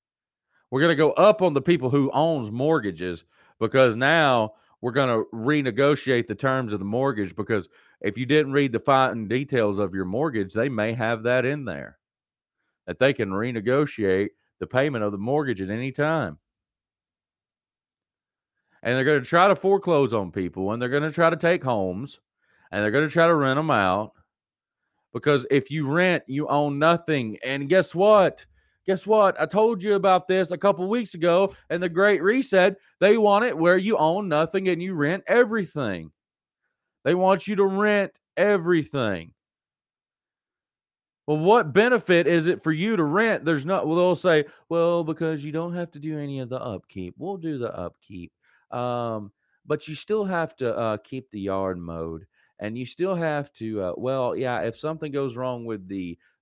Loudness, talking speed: -23 LUFS, 185 wpm